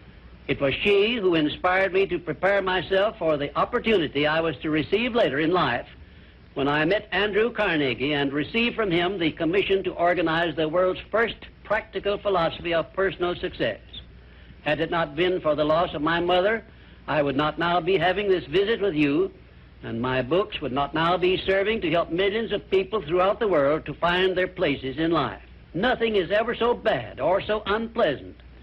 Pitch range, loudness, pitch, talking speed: 155-205 Hz, -24 LUFS, 180 Hz, 190 wpm